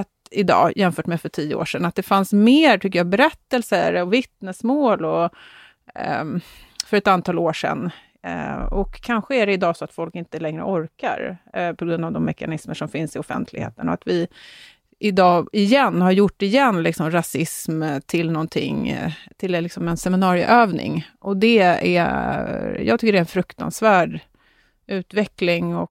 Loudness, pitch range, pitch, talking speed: -20 LUFS, 170-205 Hz, 180 Hz, 165 wpm